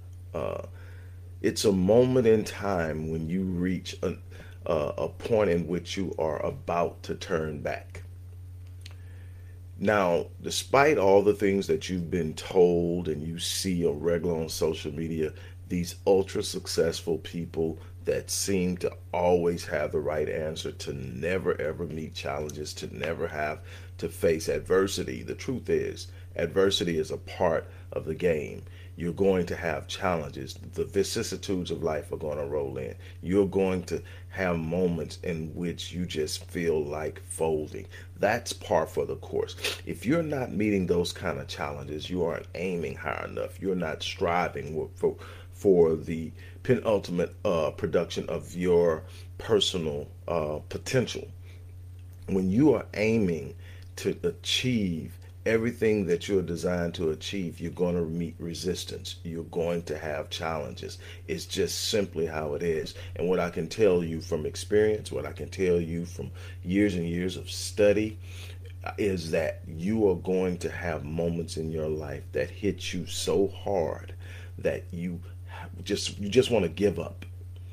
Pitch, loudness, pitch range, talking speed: 90 Hz, -29 LUFS, 85-95 Hz, 155 wpm